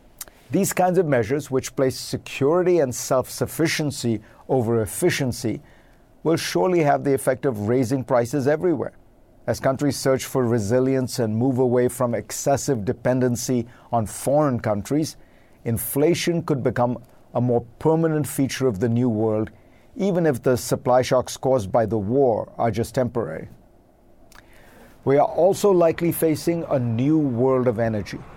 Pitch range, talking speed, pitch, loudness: 120-150 Hz, 145 wpm, 130 Hz, -22 LUFS